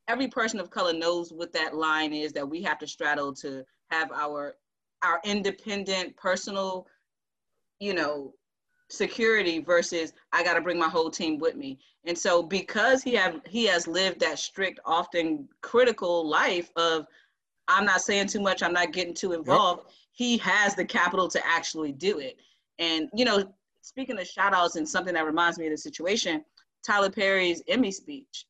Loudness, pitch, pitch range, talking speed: -26 LUFS, 180 Hz, 165-205 Hz, 175 wpm